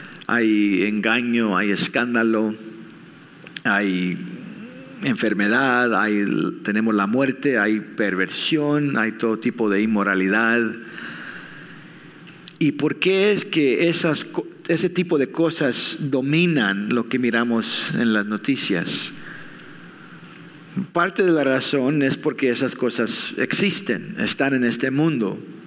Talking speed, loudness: 110 wpm, -20 LUFS